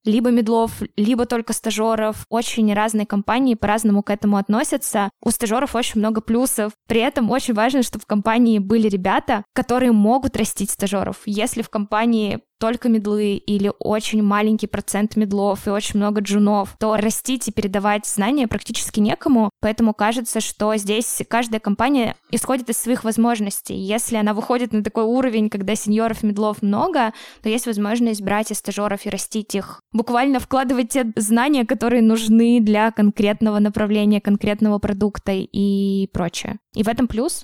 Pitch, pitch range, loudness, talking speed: 220 Hz, 210-235 Hz, -19 LUFS, 155 wpm